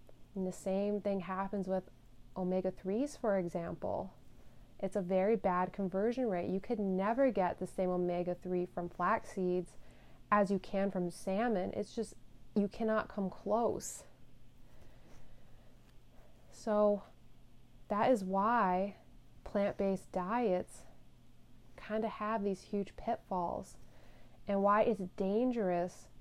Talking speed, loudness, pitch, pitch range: 125 wpm, -35 LUFS, 195 Hz, 180-210 Hz